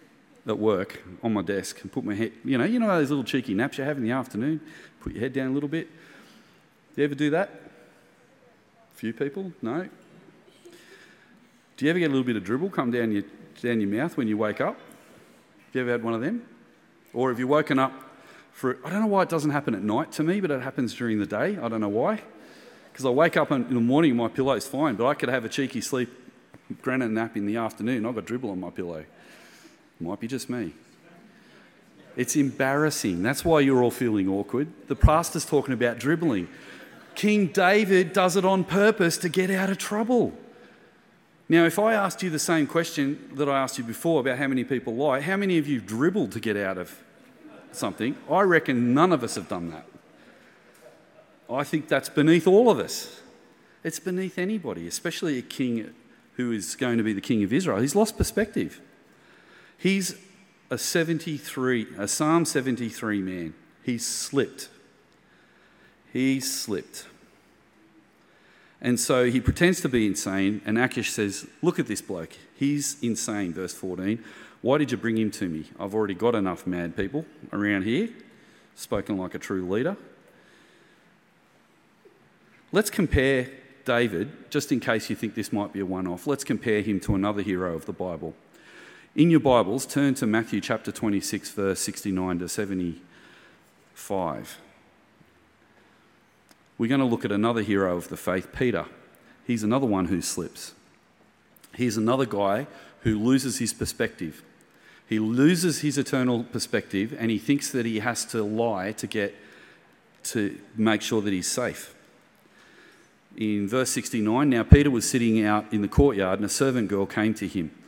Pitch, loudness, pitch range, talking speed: 125 Hz, -25 LUFS, 105-155 Hz, 180 wpm